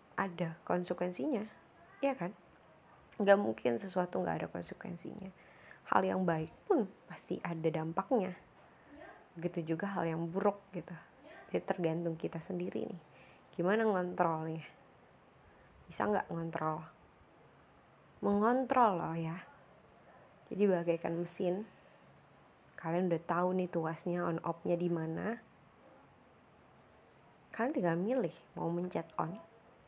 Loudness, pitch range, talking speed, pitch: -36 LUFS, 165-195 Hz, 105 wpm, 175 Hz